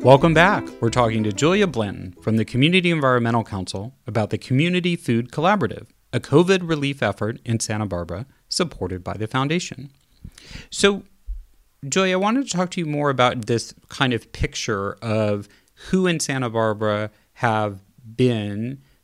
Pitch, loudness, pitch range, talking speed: 120 Hz, -21 LUFS, 105-150 Hz, 155 wpm